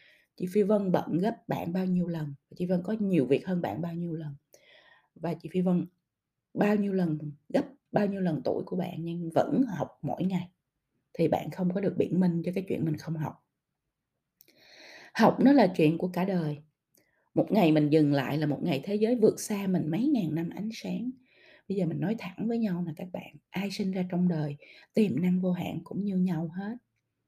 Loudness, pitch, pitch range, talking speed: -29 LUFS, 180 Hz, 160-200 Hz, 220 wpm